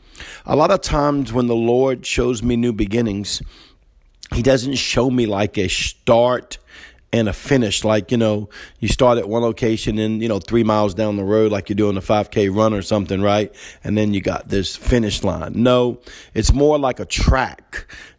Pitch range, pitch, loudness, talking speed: 105-120 Hz, 110 Hz, -18 LUFS, 195 wpm